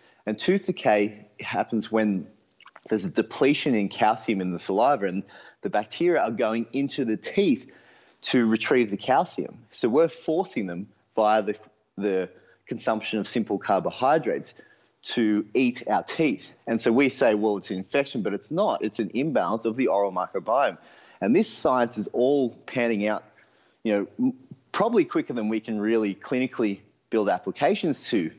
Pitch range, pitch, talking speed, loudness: 105-125 Hz, 110 Hz, 165 wpm, -25 LUFS